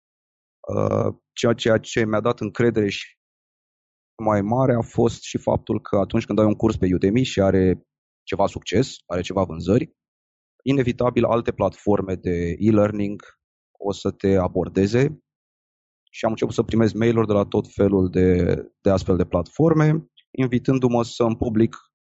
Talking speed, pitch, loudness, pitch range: 150 wpm, 105 Hz, -21 LUFS, 95-120 Hz